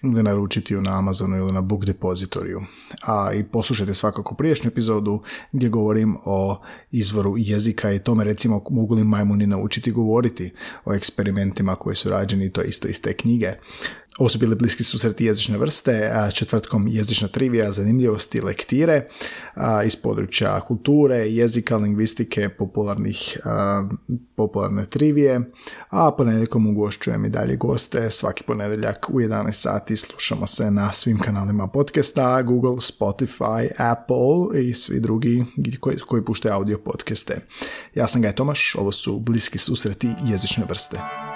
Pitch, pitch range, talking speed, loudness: 110 Hz, 100-120 Hz, 140 wpm, -21 LUFS